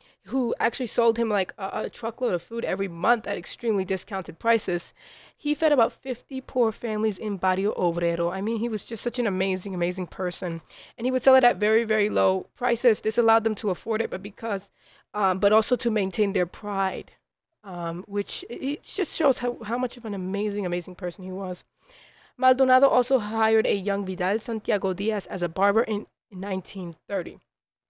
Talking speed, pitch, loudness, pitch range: 190 wpm, 210 Hz, -25 LUFS, 190-235 Hz